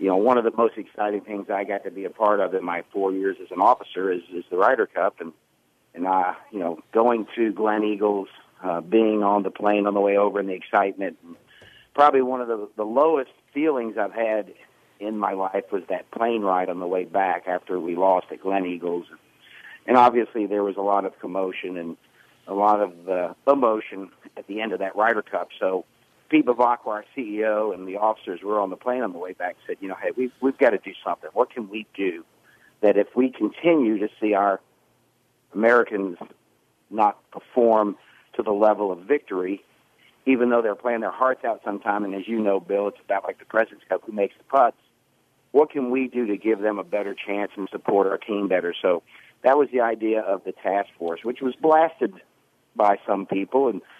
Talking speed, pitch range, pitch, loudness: 215 wpm, 95-120 Hz, 105 Hz, -23 LUFS